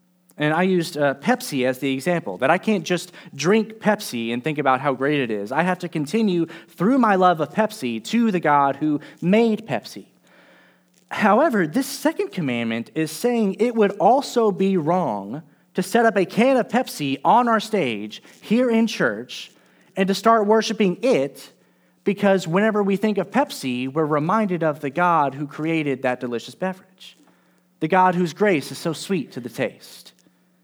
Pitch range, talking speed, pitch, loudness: 145-215 Hz, 180 wpm, 180 Hz, -21 LUFS